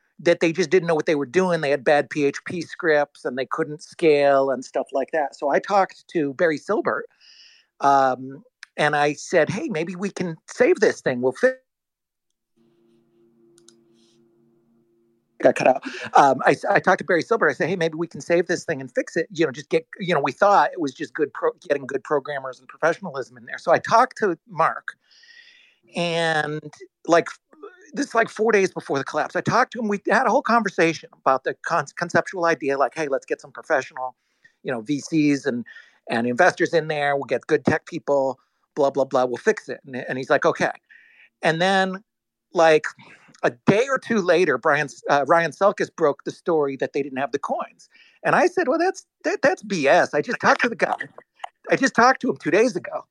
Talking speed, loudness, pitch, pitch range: 210 wpm, -21 LUFS, 165 Hz, 135-200 Hz